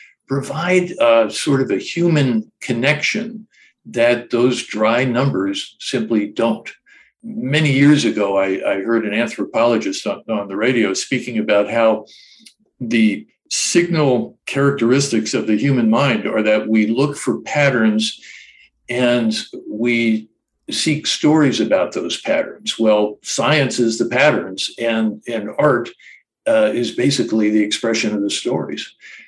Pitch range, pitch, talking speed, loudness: 110-150 Hz, 125 Hz, 130 wpm, -17 LUFS